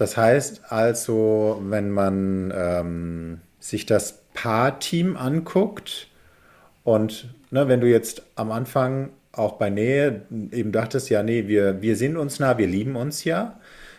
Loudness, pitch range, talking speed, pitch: -23 LUFS, 105-135 Hz, 140 wpm, 115 Hz